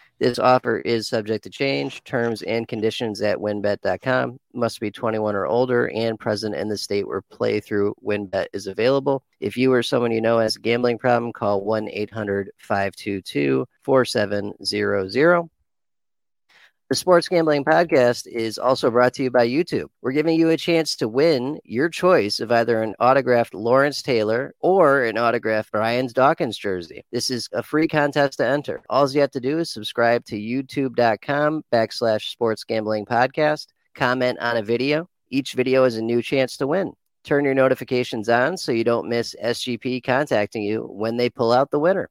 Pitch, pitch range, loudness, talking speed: 120 Hz, 110-130 Hz, -21 LUFS, 175 wpm